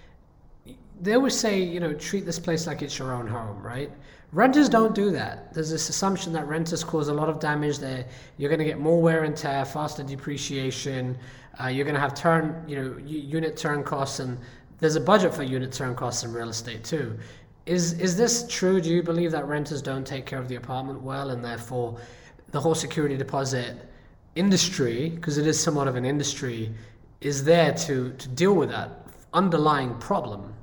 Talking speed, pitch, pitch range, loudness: 200 wpm, 145 Hz, 130-165 Hz, -26 LUFS